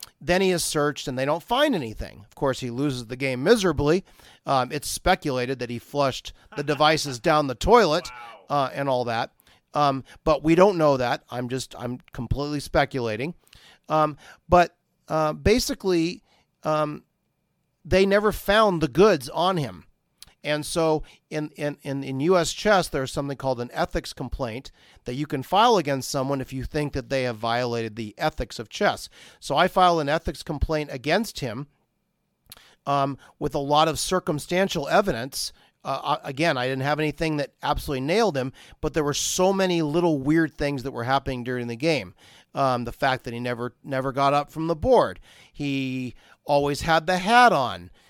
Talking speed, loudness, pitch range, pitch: 175 wpm, -24 LUFS, 130-165 Hz, 145 Hz